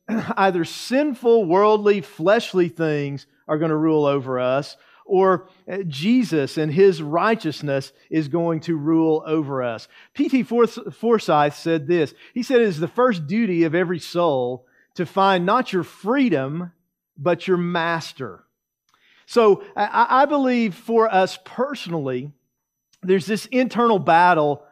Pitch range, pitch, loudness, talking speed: 155-220 Hz, 180 Hz, -20 LUFS, 130 wpm